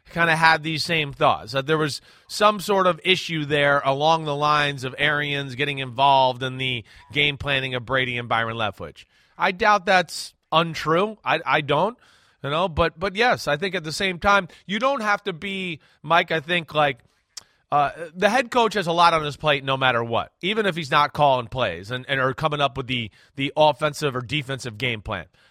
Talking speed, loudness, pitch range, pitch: 210 wpm, -22 LUFS, 135-175 Hz, 150 Hz